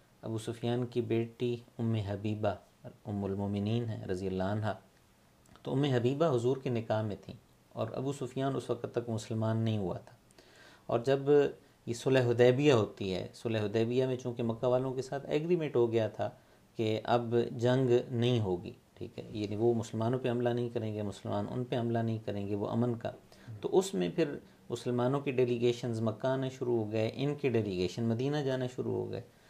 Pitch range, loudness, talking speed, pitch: 110-125 Hz, -33 LUFS, 190 wpm, 120 Hz